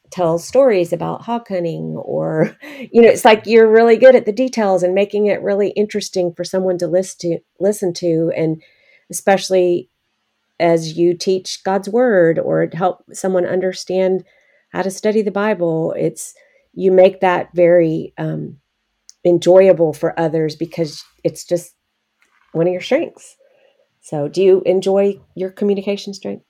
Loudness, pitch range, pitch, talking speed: -16 LUFS, 170-205 Hz, 185 Hz, 150 wpm